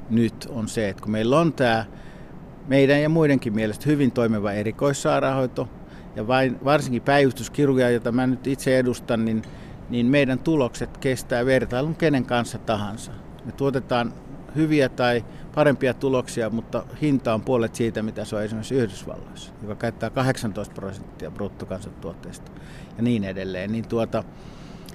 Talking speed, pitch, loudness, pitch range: 140 wpm, 120 Hz, -23 LUFS, 110-135 Hz